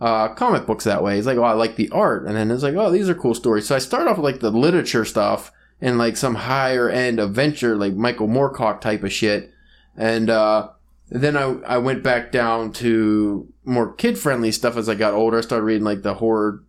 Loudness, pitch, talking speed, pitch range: -20 LUFS, 115 Hz, 235 wpm, 110-125 Hz